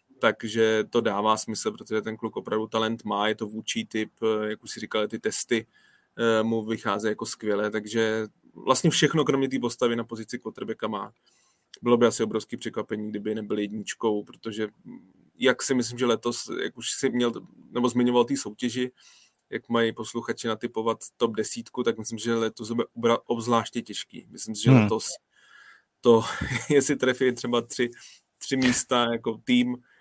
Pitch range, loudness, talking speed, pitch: 110-120 Hz, -24 LUFS, 160 wpm, 115 Hz